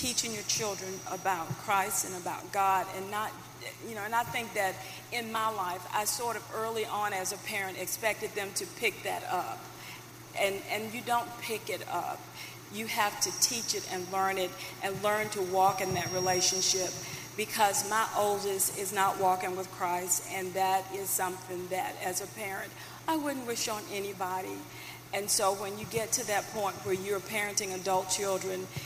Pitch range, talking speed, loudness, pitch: 185-210 Hz, 185 wpm, -31 LUFS, 195 Hz